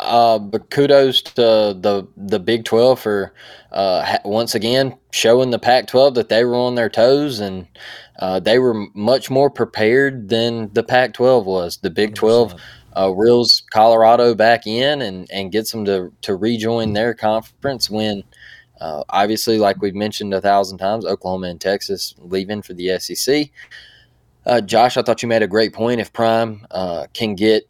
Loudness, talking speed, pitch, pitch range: -17 LUFS, 175 wpm, 110 Hz, 100-120 Hz